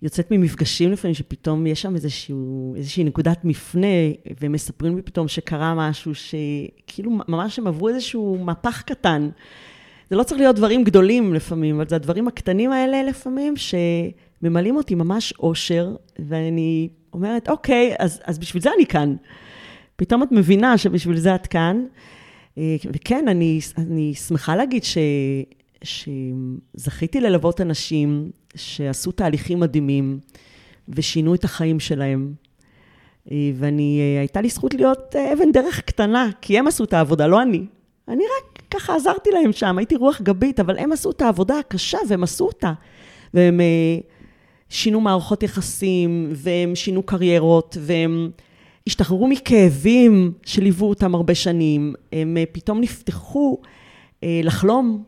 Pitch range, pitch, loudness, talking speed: 155-215 Hz, 175 Hz, -20 LUFS, 135 wpm